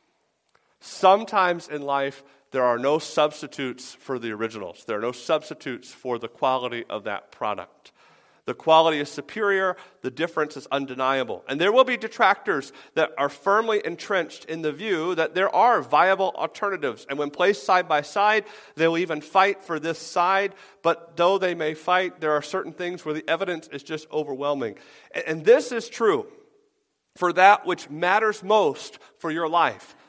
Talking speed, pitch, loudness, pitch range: 170 wpm, 165 Hz, -23 LUFS, 145-195 Hz